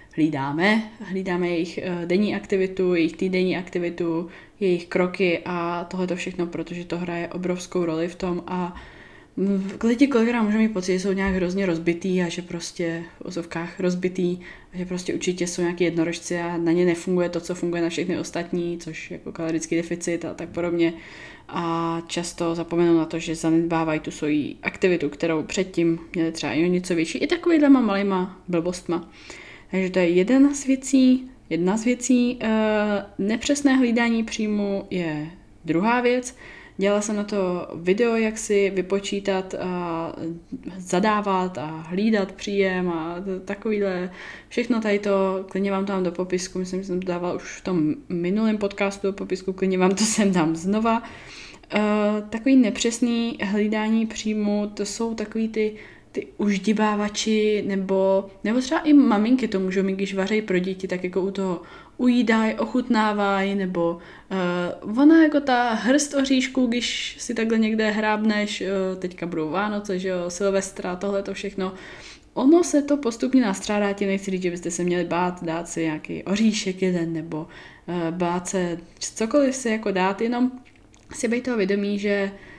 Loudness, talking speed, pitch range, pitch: -23 LUFS, 165 wpm, 175-215 Hz, 190 Hz